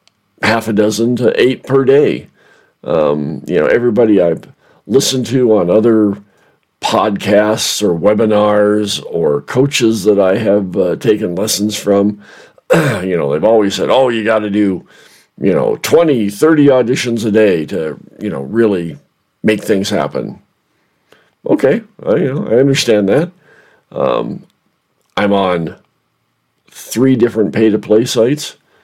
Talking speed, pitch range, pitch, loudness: 135 wpm, 105-120 Hz, 110 Hz, -13 LUFS